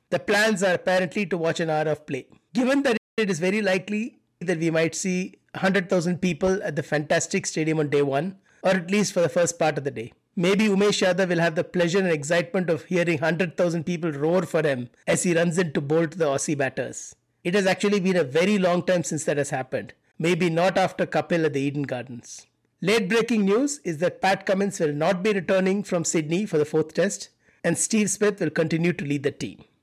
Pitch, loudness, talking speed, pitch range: 175 Hz, -24 LUFS, 220 wpm, 160-190 Hz